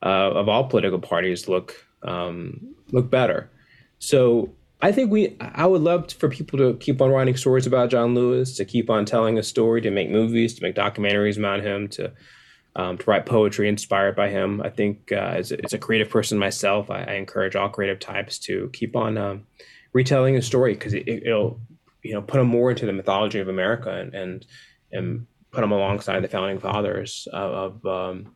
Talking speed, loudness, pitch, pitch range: 205 wpm, -22 LUFS, 110 Hz, 100-125 Hz